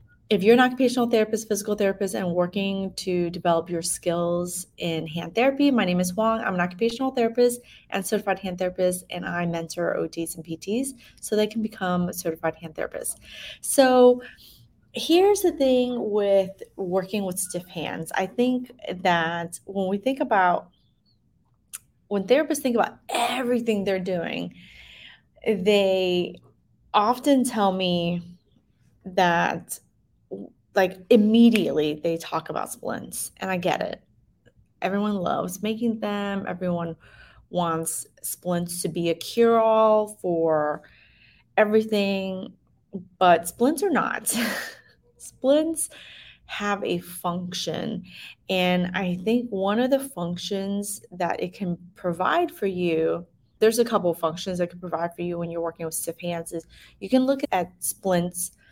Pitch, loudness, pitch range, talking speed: 190 Hz, -24 LUFS, 175-225 Hz, 140 wpm